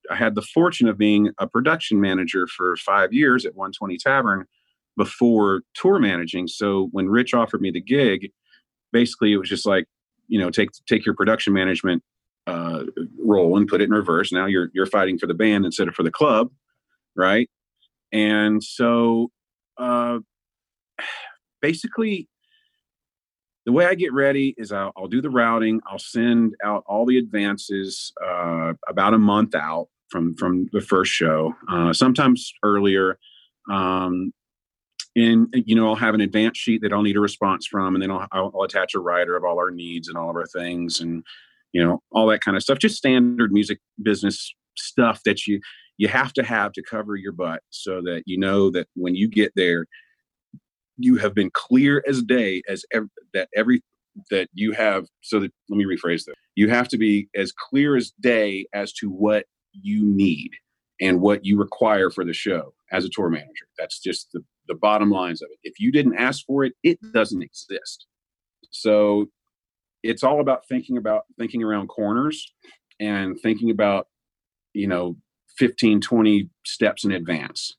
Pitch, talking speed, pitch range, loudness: 105 Hz, 180 wpm, 95-120 Hz, -21 LUFS